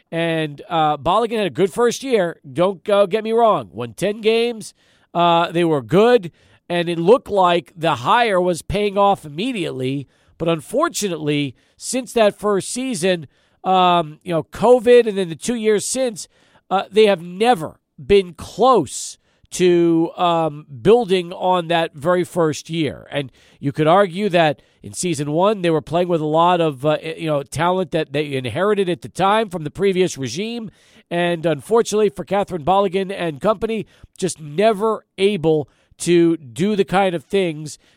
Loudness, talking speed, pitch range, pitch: -18 LUFS, 165 wpm, 160-205 Hz, 180 Hz